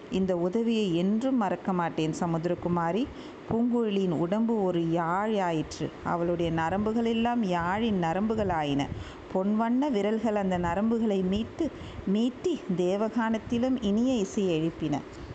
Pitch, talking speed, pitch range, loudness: 200 Hz, 95 wpm, 175-225 Hz, -28 LUFS